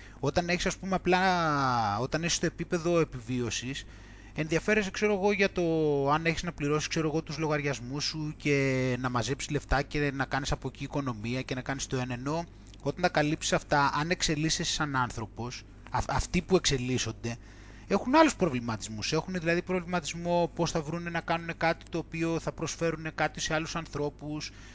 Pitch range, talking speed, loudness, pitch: 130-170 Hz, 170 wpm, -30 LUFS, 150 Hz